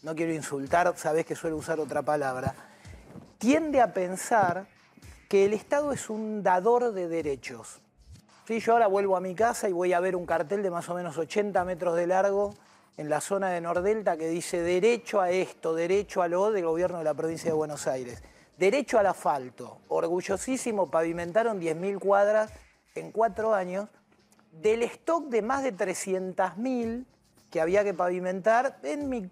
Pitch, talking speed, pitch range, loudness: 185 Hz, 170 wpm, 165-215 Hz, -28 LUFS